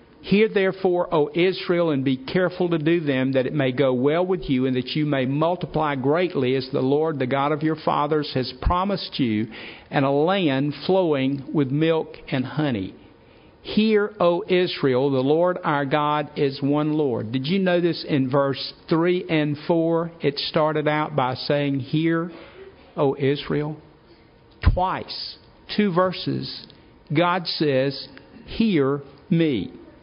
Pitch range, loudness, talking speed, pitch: 140-175 Hz, -22 LUFS, 150 wpm, 150 Hz